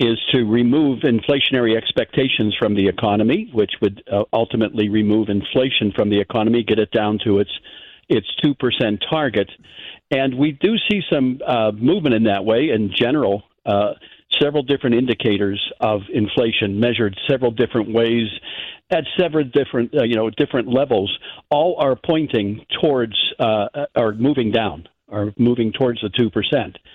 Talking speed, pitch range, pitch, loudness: 150 wpm, 105-130 Hz, 115 Hz, -18 LUFS